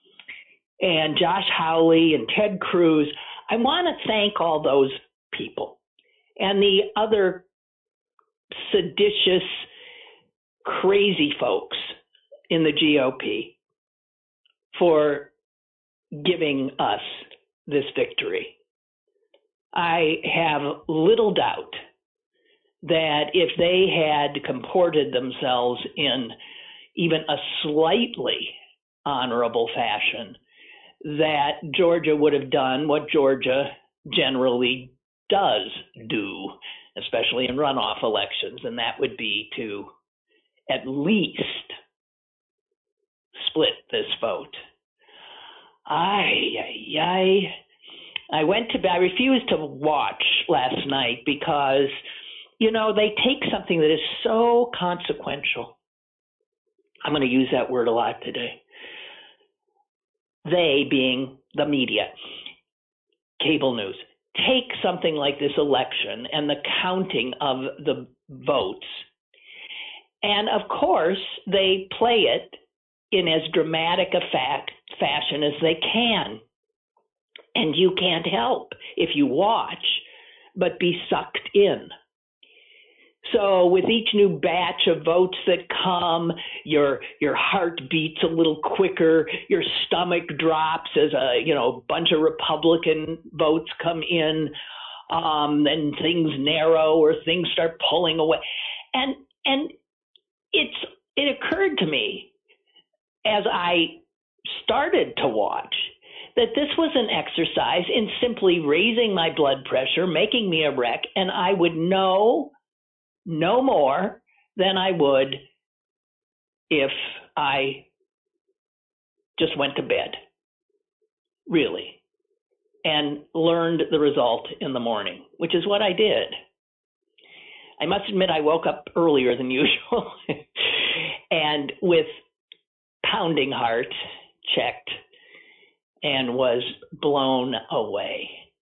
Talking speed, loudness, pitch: 110 wpm, -22 LUFS, 190 Hz